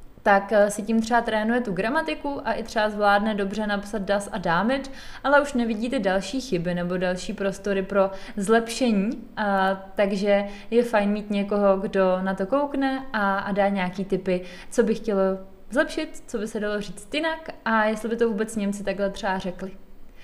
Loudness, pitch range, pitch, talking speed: -24 LUFS, 195-235 Hz, 210 Hz, 180 wpm